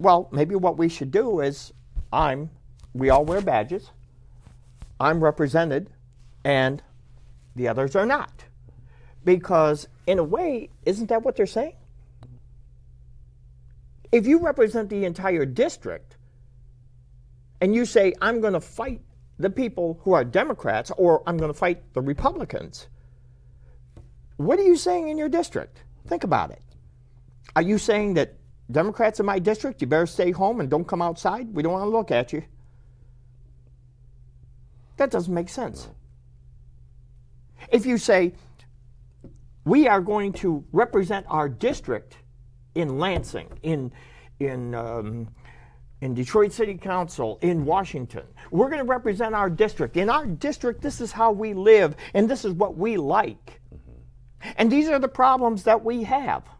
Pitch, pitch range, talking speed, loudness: 150 Hz, 125-205 Hz, 145 wpm, -23 LUFS